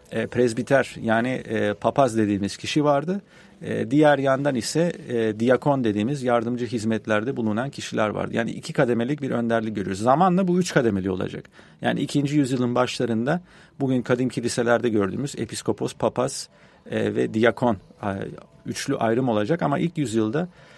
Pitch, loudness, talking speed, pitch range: 125 Hz, -23 LUFS, 145 wpm, 115-145 Hz